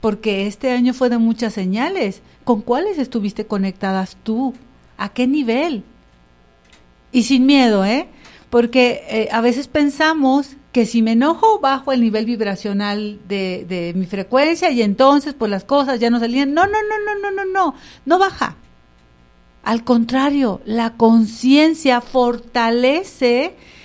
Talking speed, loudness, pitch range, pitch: 145 wpm, -17 LUFS, 210-275 Hz, 240 Hz